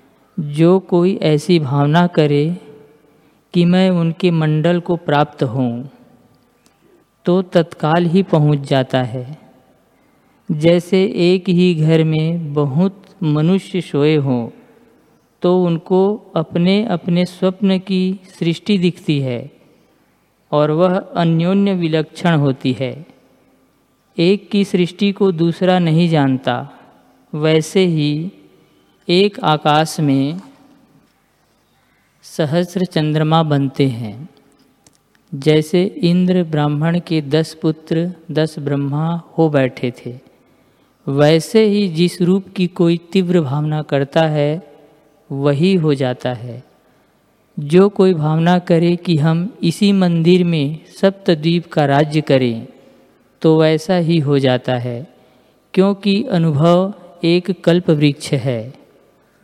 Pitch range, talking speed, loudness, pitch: 150-180 Hz, 110 wpm, -16 LUFS, 165 Hz